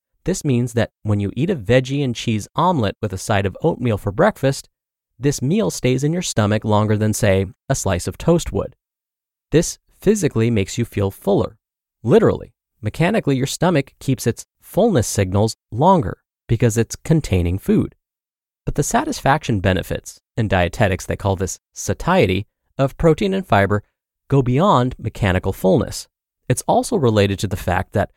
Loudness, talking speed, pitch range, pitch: -19 LUFS, 160 wpm, 100-140 Hz, 115 Hz